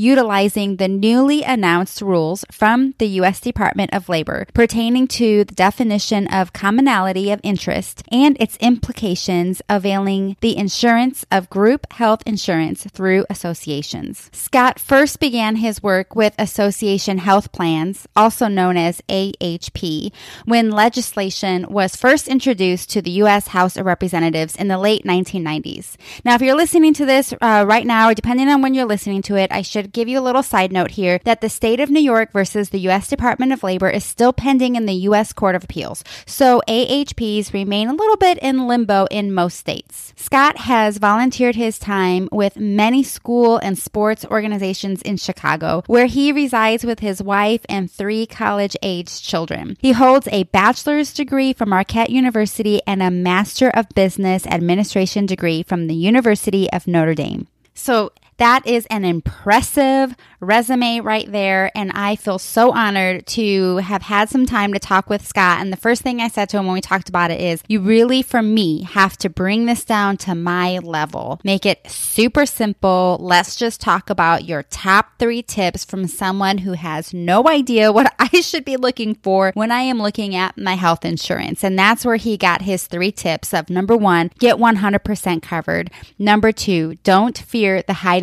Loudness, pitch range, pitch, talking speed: -16 LUFS, 190-235 Hz, 205 Hz, 180 wpm